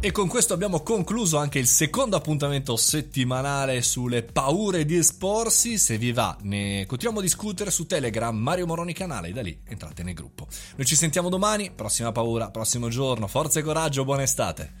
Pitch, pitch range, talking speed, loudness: 140 Hz, 115-180 Hz, 180 wpm, -23 LUFS